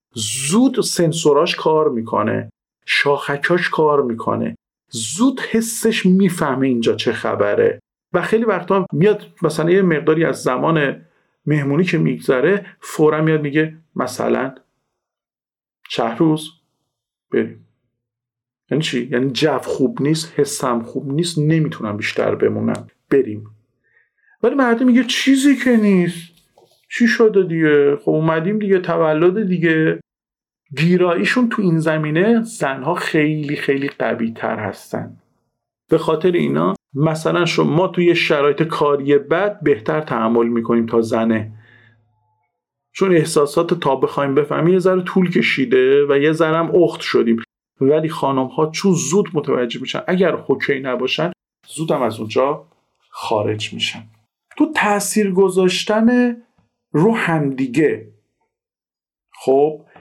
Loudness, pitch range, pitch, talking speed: -17 LUFS, 130-185 Hz, 155 Hz, 120 wpm